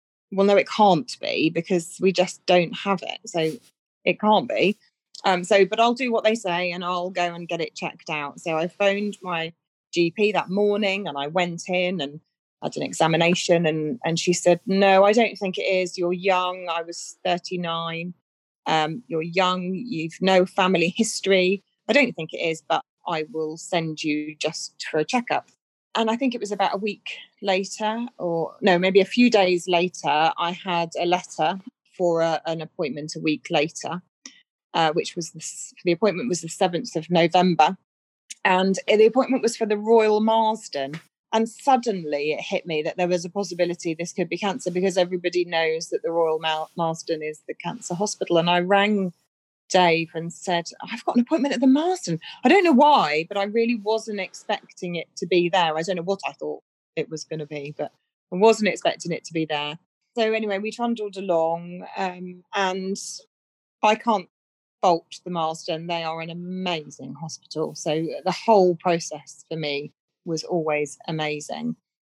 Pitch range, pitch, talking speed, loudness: 165-200 Hz, 180 Hz, 185 wpm, -23 LUFS